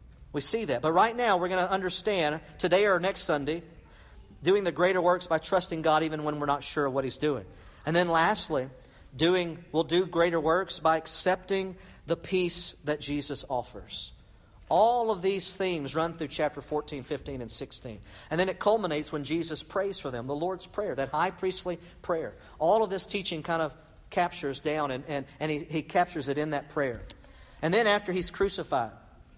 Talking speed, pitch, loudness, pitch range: 190 wpm, 160 Hz, -29 LUFS, 145-185 Hz